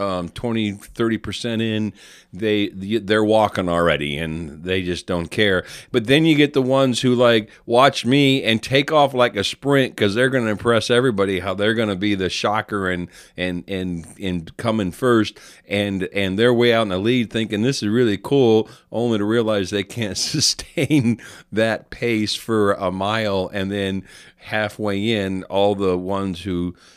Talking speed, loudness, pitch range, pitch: 175 wpm, -20 LUFS, 95-120 Hz, 105 Hz